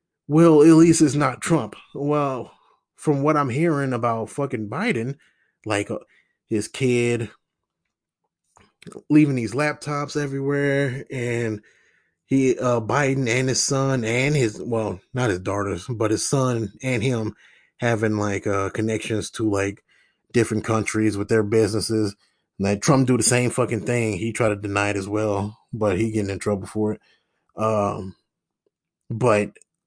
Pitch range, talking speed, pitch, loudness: 105-135 Hz, 150 wpm, 115 Hz, -22 LUFS